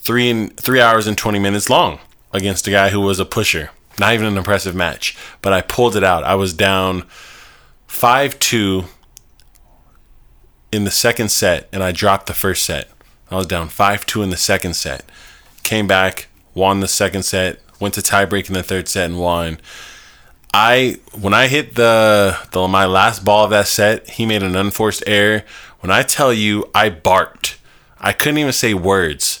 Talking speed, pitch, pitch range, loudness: 190 wpm, 100 Hz, 95-105 Hz, -15 LUFS